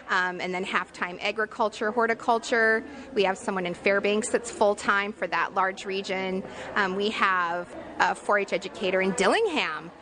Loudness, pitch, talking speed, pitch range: -26 LUFS, 200 Hz, 170 wpm, 190-220 Hz